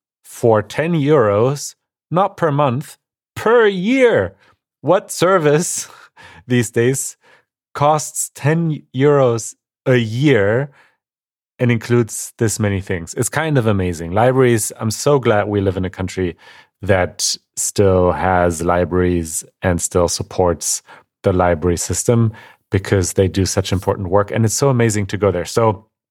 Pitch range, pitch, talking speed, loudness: 95-135 Hz, 110 Hz, 135 wpm, -17 LUFS